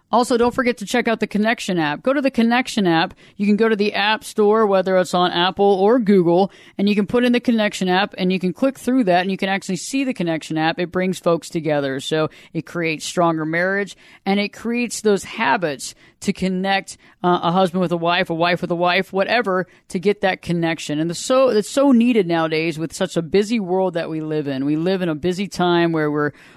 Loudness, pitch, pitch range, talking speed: -19 LUFS, 190 Hz, 170-215 Hz, 245 wpm